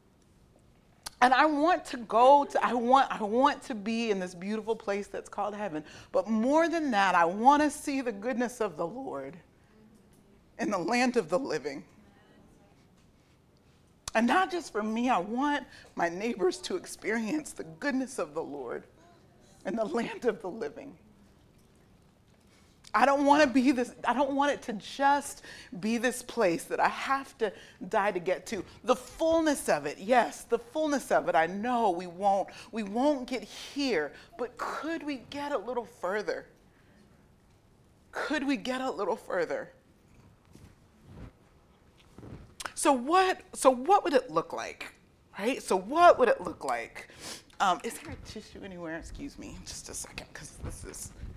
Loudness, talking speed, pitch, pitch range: -29 LUFS, 165 wpm, 255 Hz, 220-290 Hz